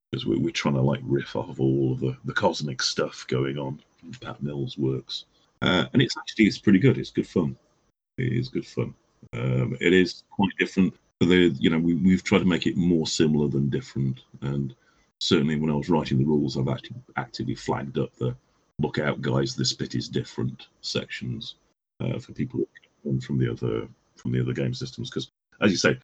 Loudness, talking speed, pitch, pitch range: -26 LUFS, 205 wpm, 70 Hz, 65-75 Hz